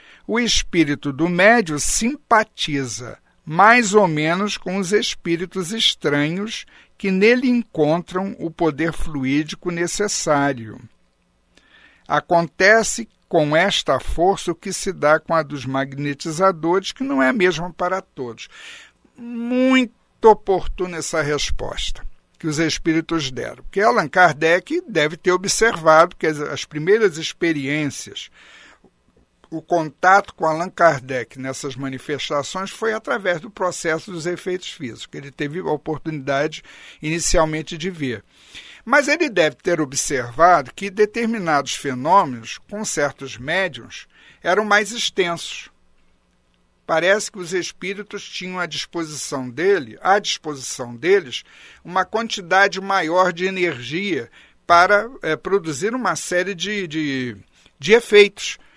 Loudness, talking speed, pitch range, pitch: -19 LUFS, 120 wpm, 150-200 Hz, 170 Hz